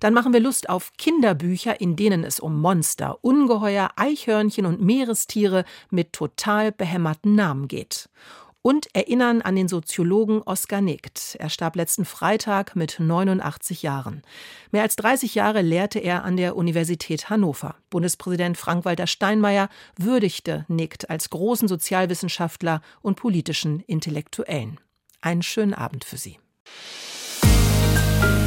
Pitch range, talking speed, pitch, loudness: 165-210 Hz, 125 wpm, 180 Hz, -22 LUFS